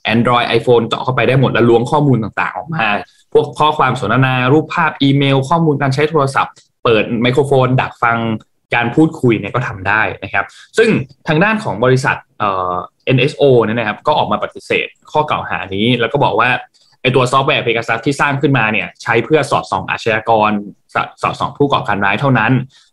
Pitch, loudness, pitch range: 125 Hz, -14 LUFS, 115-150 Hz